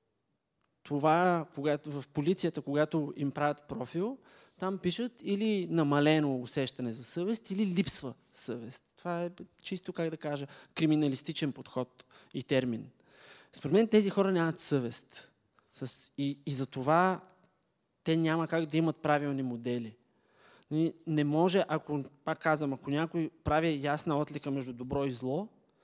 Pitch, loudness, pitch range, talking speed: 150 Hz, -32 LUFS, 140-175 Hz, 135 wpm